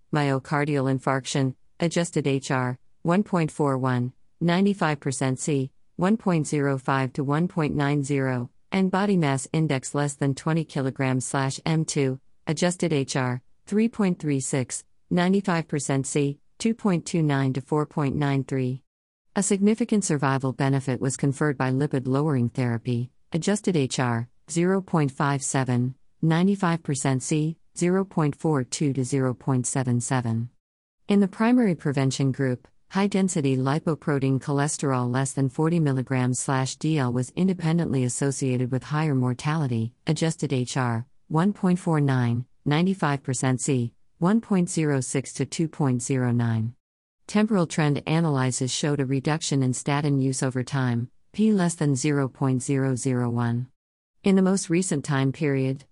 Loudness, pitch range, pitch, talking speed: -25 LUFS, 130-165 Hz, 140 Hz, 100 wpm